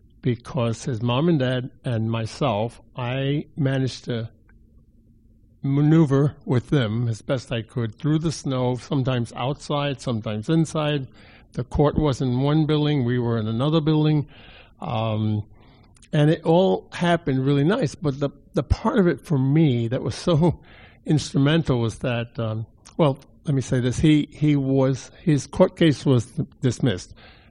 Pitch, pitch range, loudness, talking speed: 130 Hz, 115-150 Hz, -23 LUFS, 155 wpm